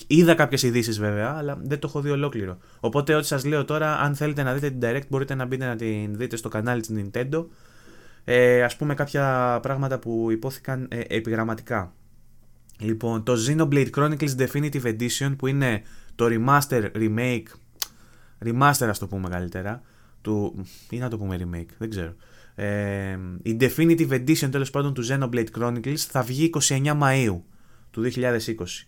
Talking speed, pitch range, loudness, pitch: 165 wpm, 110-140 Hz, -24 LUFS, 120 Hz